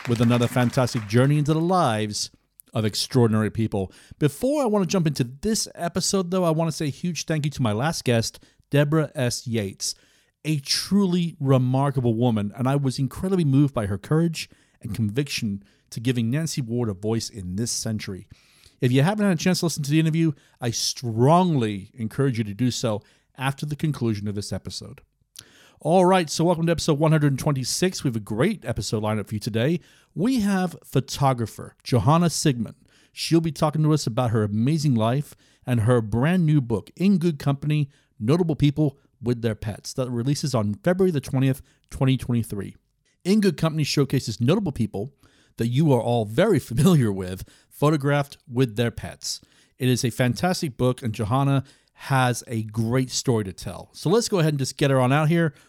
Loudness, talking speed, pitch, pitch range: -23 LUFS, 185 wpm, 135 Hz, 115-155 Hz